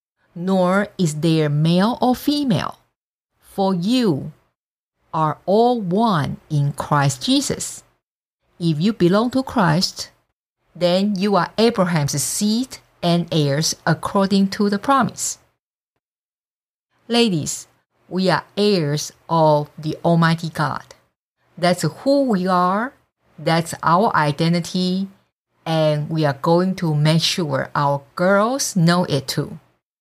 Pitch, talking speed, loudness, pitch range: 175 Hz, 115 wpm, -19 LUFS, 155-200 Hz